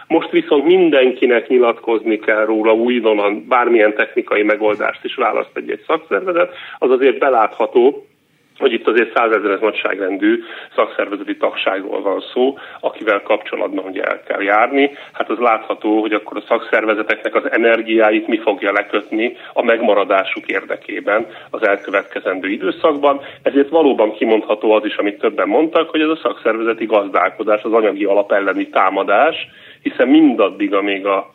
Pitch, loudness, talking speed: 155 Hz, -16 LUFS, 140 wpm